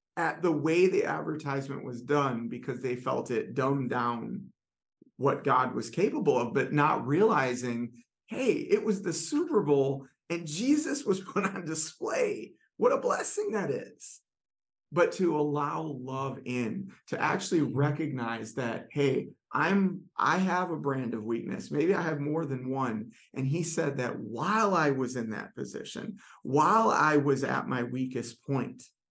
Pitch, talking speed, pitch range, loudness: 140 Hz, 160 wpm, 130-180 Hz, -30 LUFS